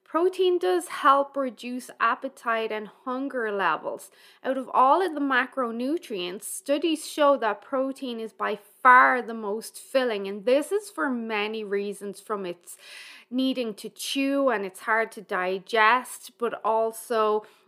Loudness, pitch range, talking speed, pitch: -25 LUFS, 215-275 Hz, 145 wpm, 250 Hz